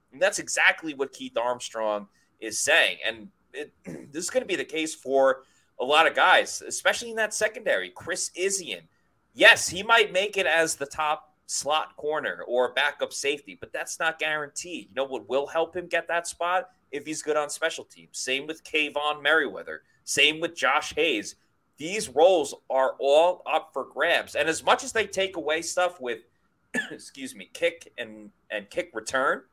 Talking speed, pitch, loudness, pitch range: 185 wpm, 165 Hz, -25 LUFS, 145-230 Hz